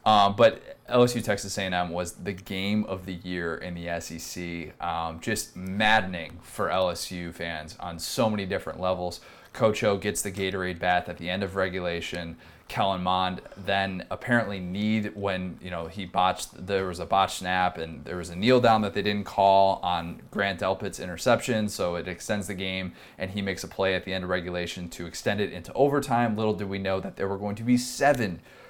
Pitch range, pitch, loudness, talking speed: 90-100 Hz, 95 Hz, -27 LUFS, 200 wpm